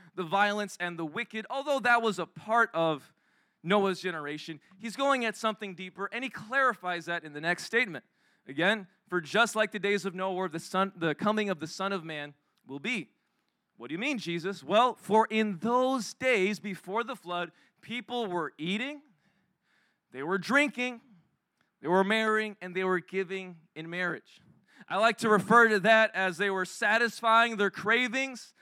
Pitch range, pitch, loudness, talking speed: 180-230 Hz, 200 Hz, -29 LUFS, 180 wpm